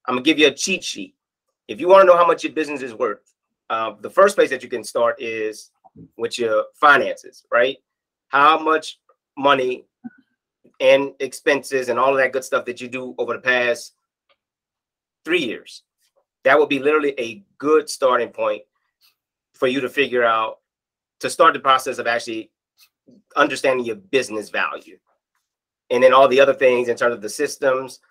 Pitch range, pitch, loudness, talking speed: 125-190 Hz, 140 Hz, -18 LUFS, 175 wpm